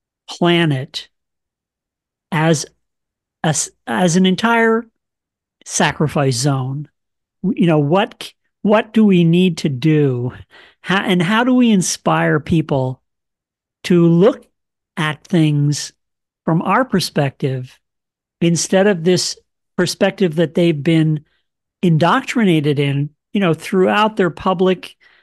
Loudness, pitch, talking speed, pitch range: -16 LUFS, 170 Hz, 105 wpm, 150-190 Hz